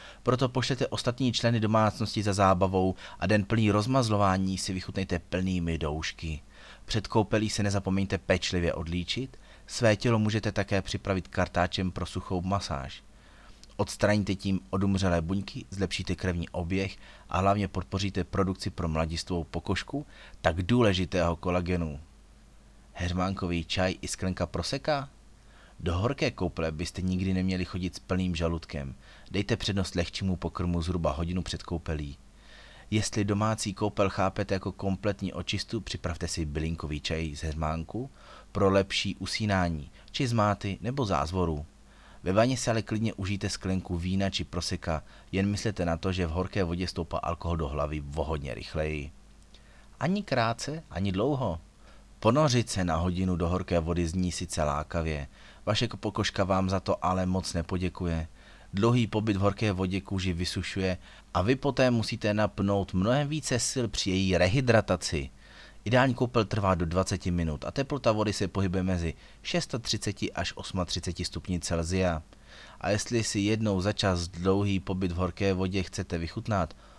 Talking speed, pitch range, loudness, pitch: 145 wpm, 85-105 Hz, -29 LUFS, 95 Hz